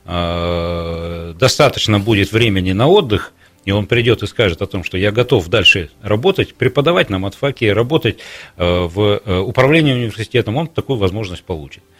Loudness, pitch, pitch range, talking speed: -15 LUFS, 100 Hz, 90-115 Hz, 140 wpm